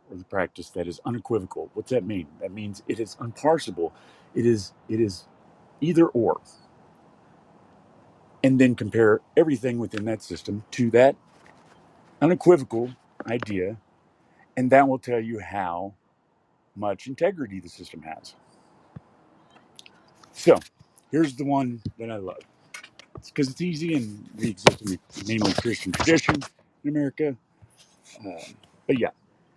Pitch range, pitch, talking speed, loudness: 105-135 Hz, 115 Hz, 135 wpm, -25 LUFS